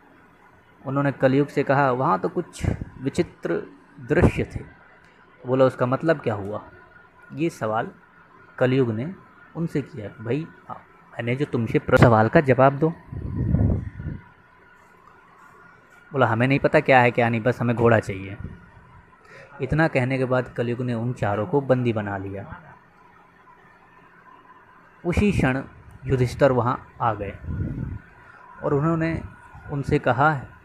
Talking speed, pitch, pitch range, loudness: 125 wpm, 130 Hz, 115-145 Hz, -23 LUFS